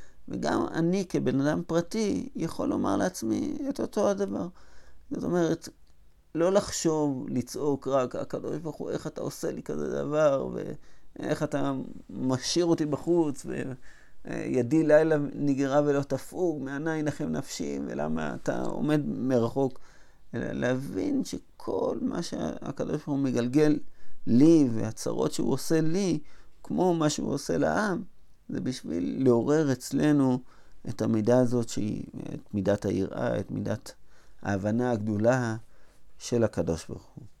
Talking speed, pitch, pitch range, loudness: 125 wpm, 135 Hz, 115-155 Hz, -28 LUFS